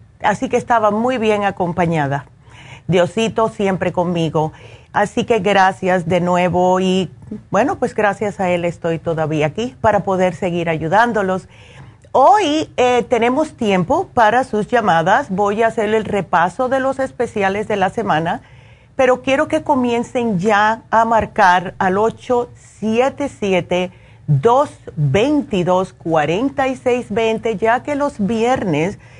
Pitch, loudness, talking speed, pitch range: 205 Hz, -17 LUFS, 135 wpm, 180-240 Hz